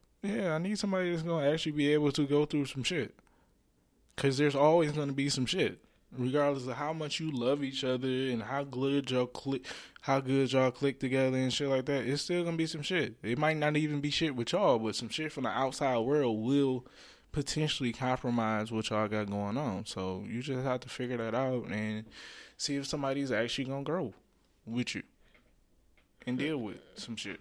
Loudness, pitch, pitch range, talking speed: -32 LUFS, 135 Hz, 125-150 Hz, 205 wpm